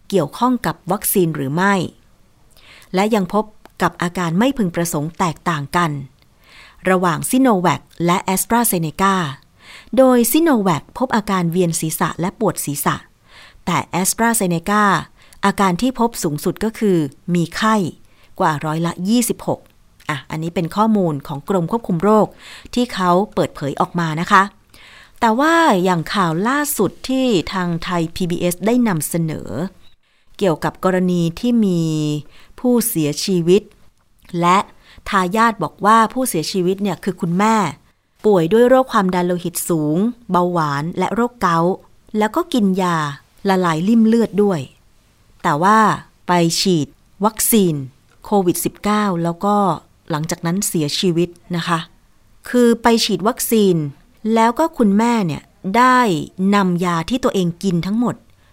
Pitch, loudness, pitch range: 185 Hz, -17 LUFS, 170-215 Hz